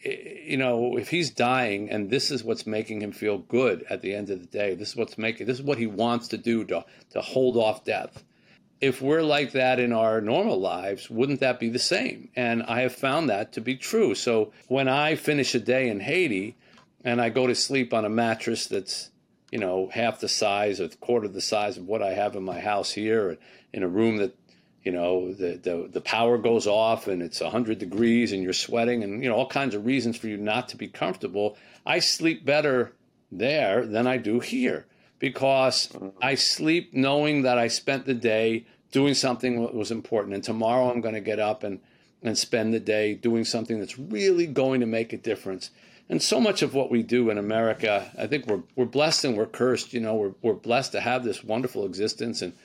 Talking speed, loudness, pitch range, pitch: 220 wpm, -25 LUFS, 110-130 Hz, 120 Hz